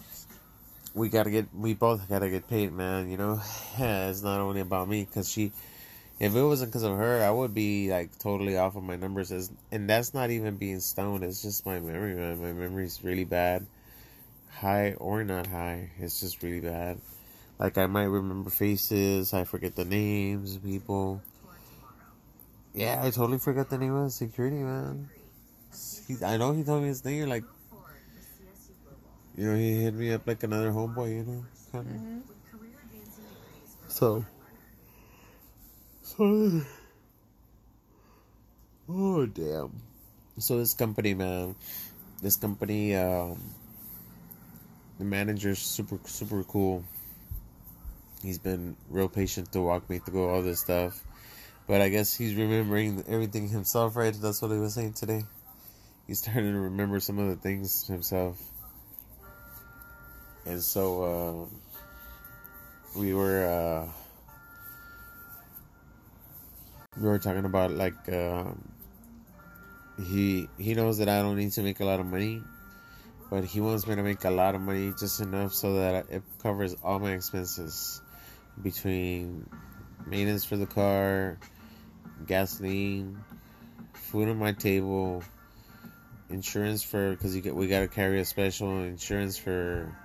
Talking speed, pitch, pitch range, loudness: 140 wpm, 100 Hz, 95-110 Hz, -30 LUFS